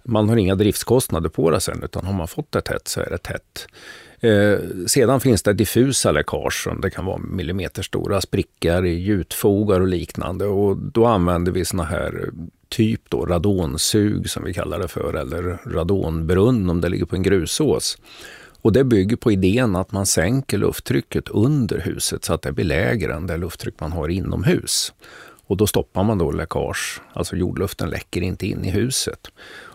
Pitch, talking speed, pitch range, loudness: 95 Hz, 180 wpm, 90-110 Hz, -20 LUFS